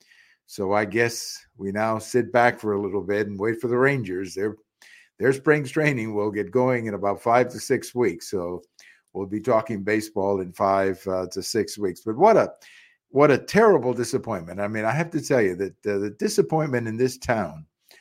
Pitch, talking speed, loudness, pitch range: 110 Hz, 205 wpm, -23 LUFS, 100-125 Hz